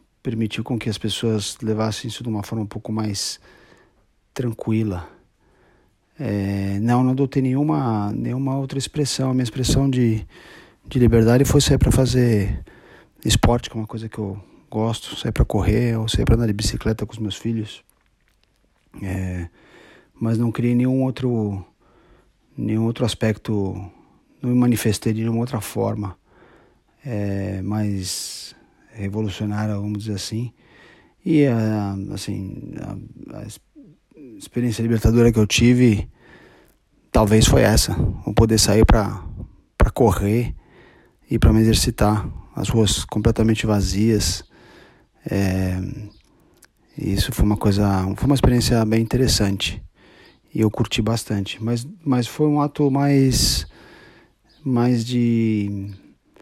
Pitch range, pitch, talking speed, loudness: 105-120 Hz, 110 Hz, 130 wpm, -20 LUFS